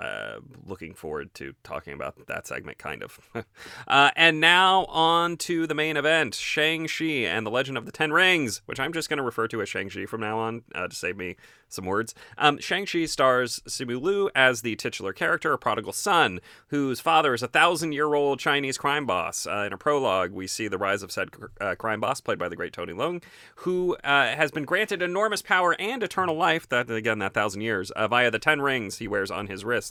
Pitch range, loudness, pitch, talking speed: 115-165 Hz, -24 LUFS, 145 Hz, 220 wpm